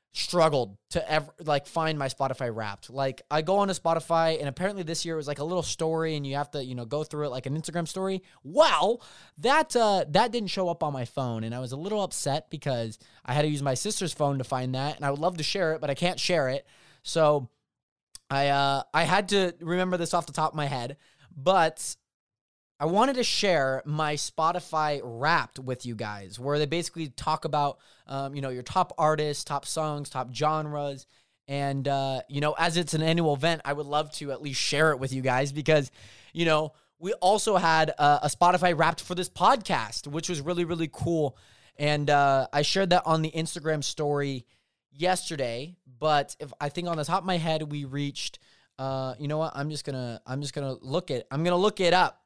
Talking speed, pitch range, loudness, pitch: 225 wpm, 140-170 Hz, -27 LUFS, 150 Hz